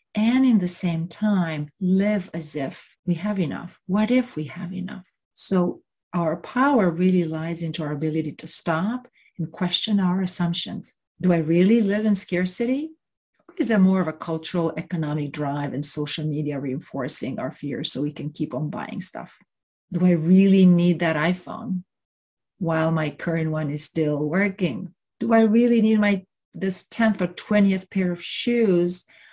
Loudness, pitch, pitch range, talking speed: -23 LUFS, 180 Hz, 160-200 Hz, 170 wpm